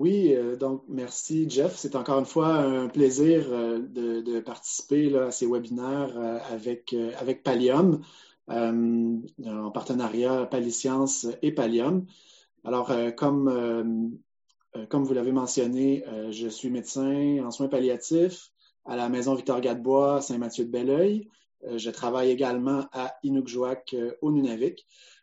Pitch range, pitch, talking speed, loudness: 120-140 Hz, 130 Hz, 150 wpm, -27 LUFS